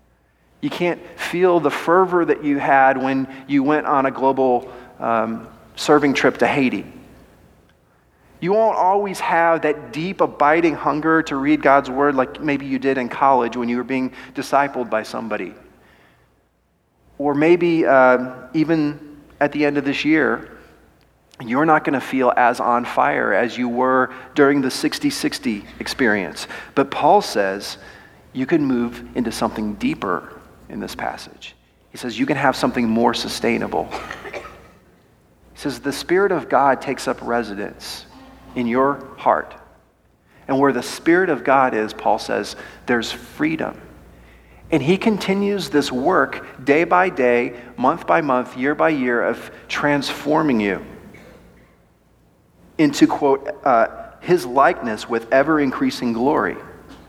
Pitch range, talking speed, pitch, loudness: 125-165 Hz, 145 wpm, 140 Hz, -19 LUFS